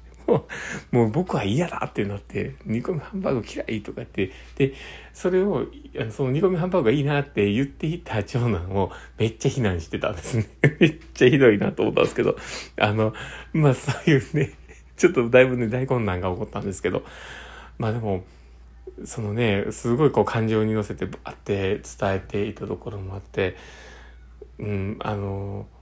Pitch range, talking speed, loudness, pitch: 100-130 Hz, 350 characters per minute, -24 LUFS, 110 Hz